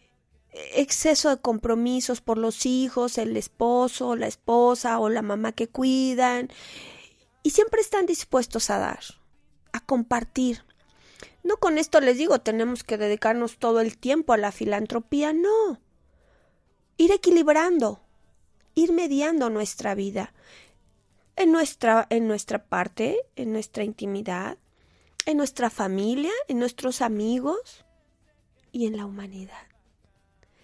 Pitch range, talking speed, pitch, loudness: 220-300 Hz, 120 wpm, 245 Hz, -24 LUFS